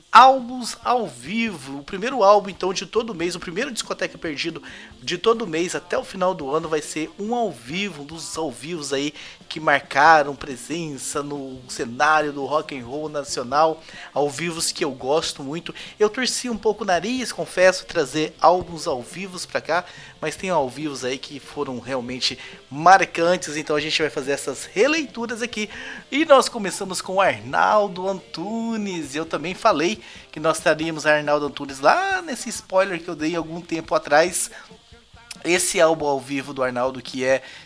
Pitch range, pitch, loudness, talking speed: 145-200 Hz, 165 Hz, -22 LUFS, 175 wpm